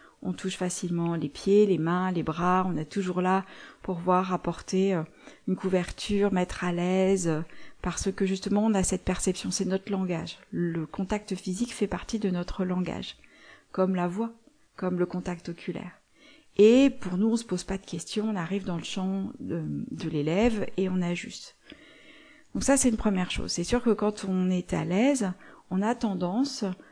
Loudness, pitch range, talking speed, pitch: -28 LUFS, 180-205 Hz, 185 wpm, 190 Hz